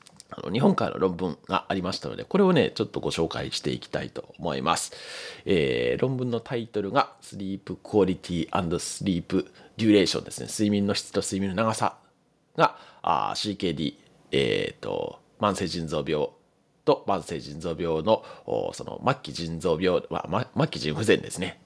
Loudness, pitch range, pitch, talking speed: -27 LUFS, 95-120 Hz, 105 Hz, 330 characters per minute